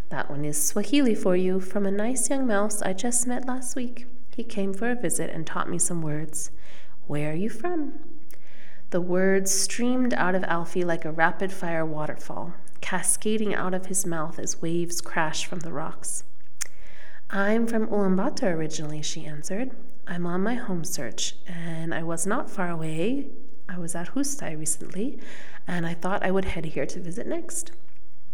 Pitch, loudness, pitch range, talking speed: 190 Hz, -28 LUFS, 165-235 Hz, 180 wpm